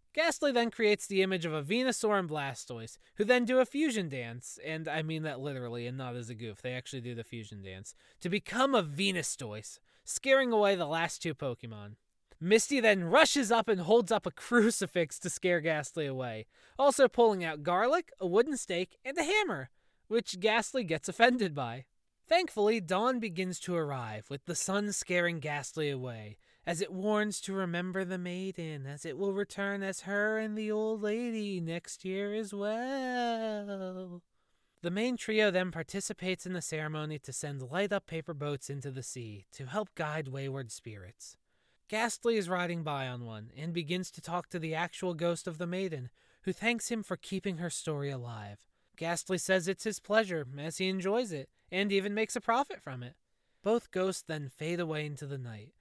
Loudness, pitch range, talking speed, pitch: -32 LUFS, 145-215 Hz, 185 wpm, 180 Hz